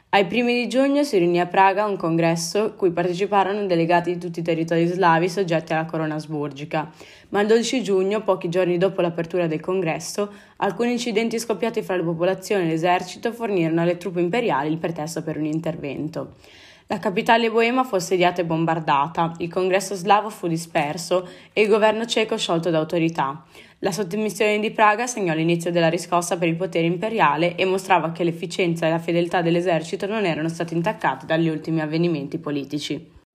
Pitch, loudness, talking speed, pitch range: 180 Hz, -22 LUFS, 175 wpm, 165-205 Hz